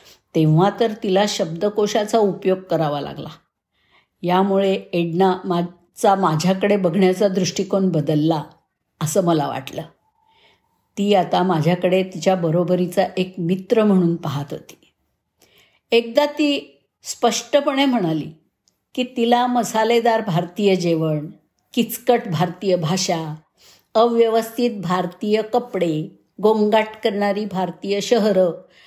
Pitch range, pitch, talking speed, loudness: 175-220 Hz, 190 Hz, 95 wpm, -19 LUFS